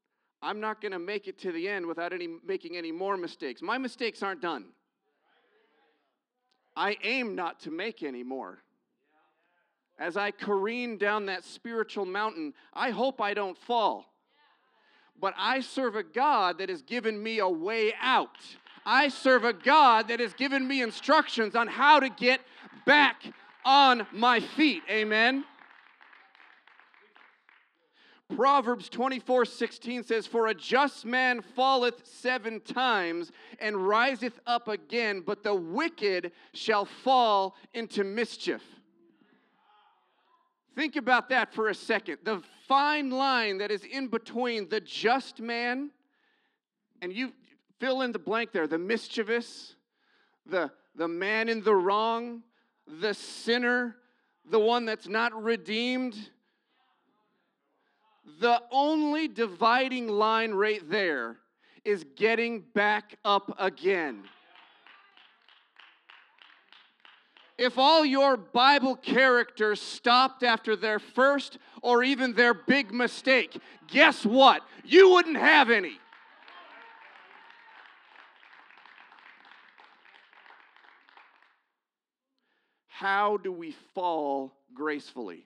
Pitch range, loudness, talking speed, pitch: 210-270 Hz, -27 LUFS, 115 wpm, 240 Hz